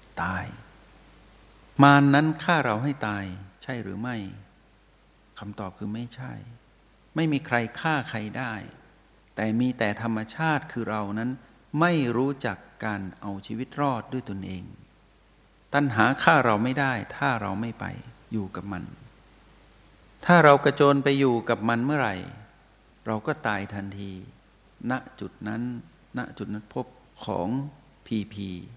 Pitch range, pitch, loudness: 105-140 Hz, 115 Hz, -26 LUFS